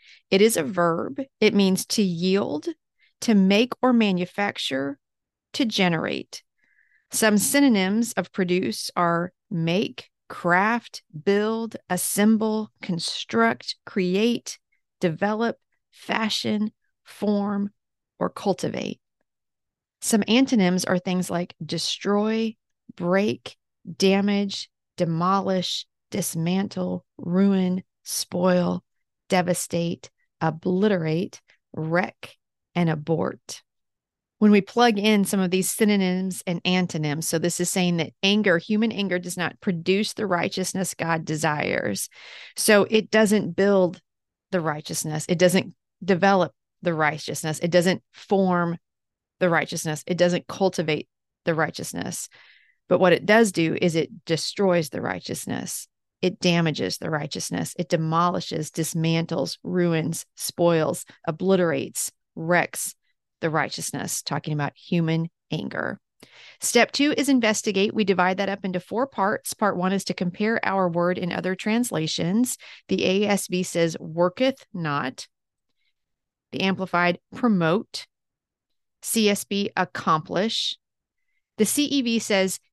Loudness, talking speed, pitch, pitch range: -24 LUFS, 110 wpm, 185 Hz, 170-210 Hz